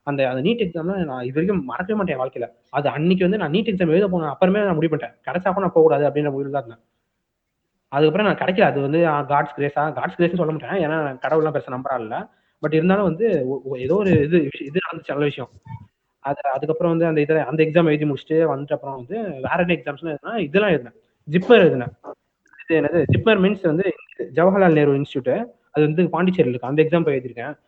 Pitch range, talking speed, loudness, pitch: 140-180 Hz, 160 wpm, -20 LUFS, 155 Hz